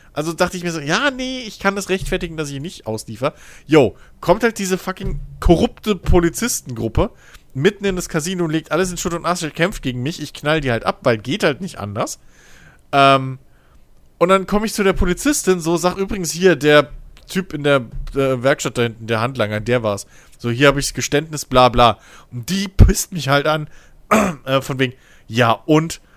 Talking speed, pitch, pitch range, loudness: 205 wpm, 155 Hz, 130-185 Hz, -18 LUFS